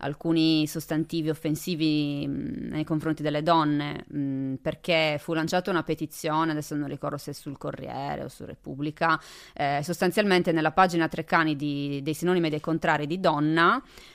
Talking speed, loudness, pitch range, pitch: 155 wpm, -26 LUFS, 150-165 Hz, 155 Hz